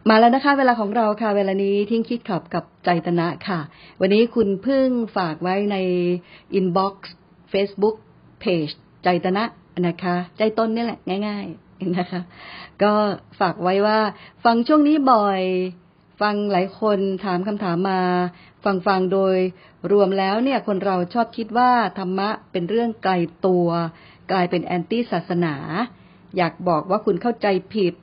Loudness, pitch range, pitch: -21 LUFS, 180-215 Hz, 195 Hz